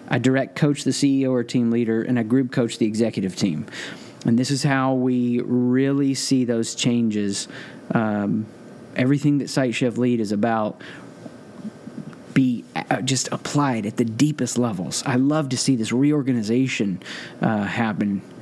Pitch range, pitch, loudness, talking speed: 115-135 Hz, 125 Hz, -22 LUFS, 155 wpm